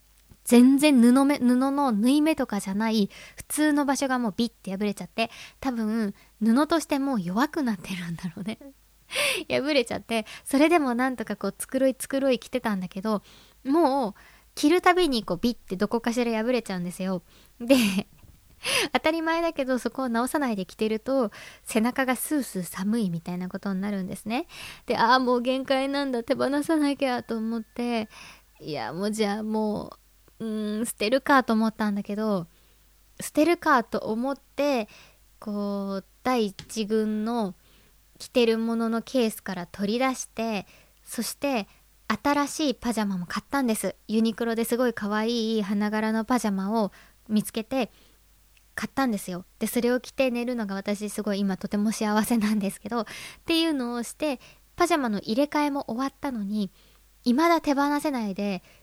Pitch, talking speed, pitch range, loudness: 230 Hz, 335 characters per minute, 210-270 Hz, -26 LUFS